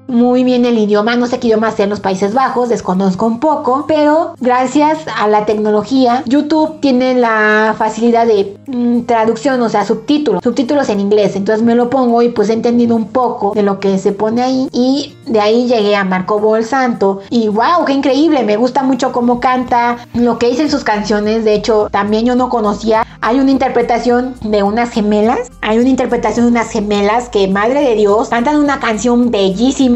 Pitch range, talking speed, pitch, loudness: 215-255 Hz, 195 wpm, 235 Hz, -12 LUFS